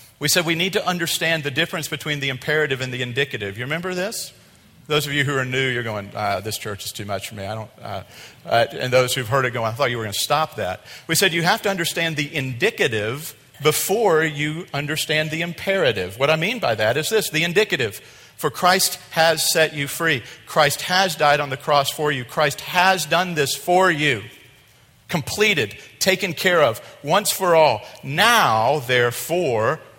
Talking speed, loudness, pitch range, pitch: 205 wpm, -20 LUFS, 130-170 Hz, 150 Hz